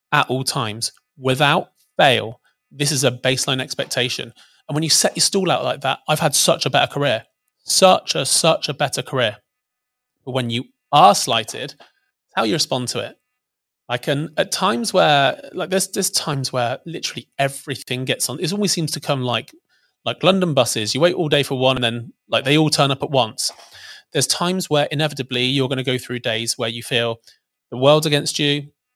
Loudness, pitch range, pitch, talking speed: -19 LUFS, 130-170 Hz, 145 Hz, 200 wpm